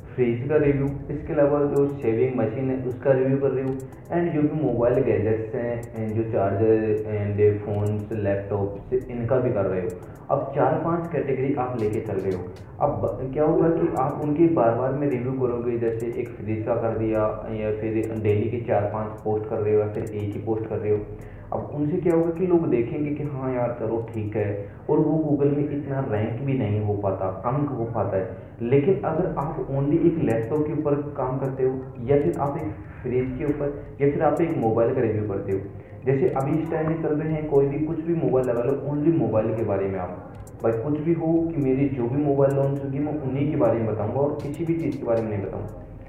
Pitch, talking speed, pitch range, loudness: 125 Hz, 230 wpm, 110-145 Hz, -24 LUFS